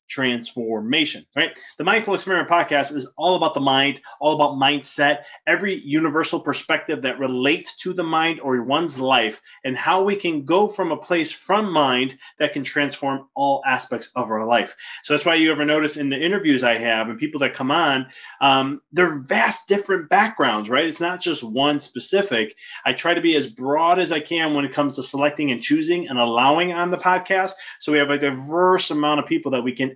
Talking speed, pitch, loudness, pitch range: 205 wpm, 150 Hz, -20 LUFS, 135-170 Hz